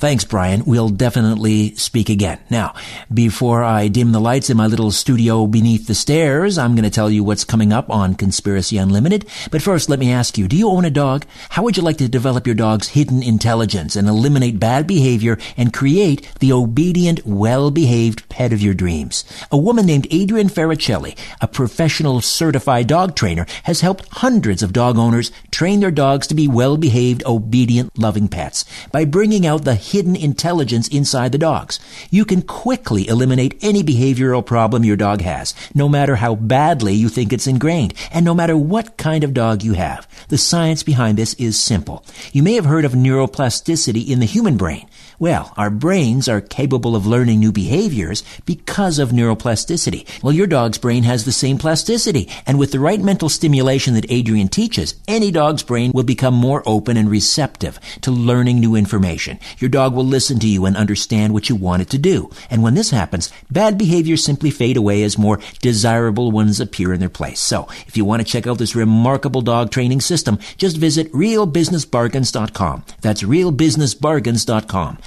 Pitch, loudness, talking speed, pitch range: 125 Hz, -16 LUFS, 185 wpm, 110-150 Hz